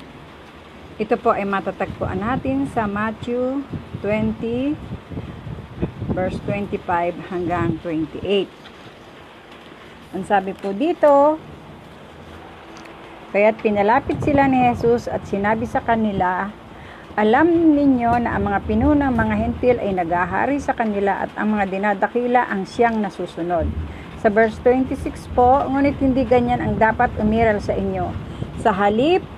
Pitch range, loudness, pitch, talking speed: 195-250 Hz, -20 LUFS, 220 Hz, 120 wpm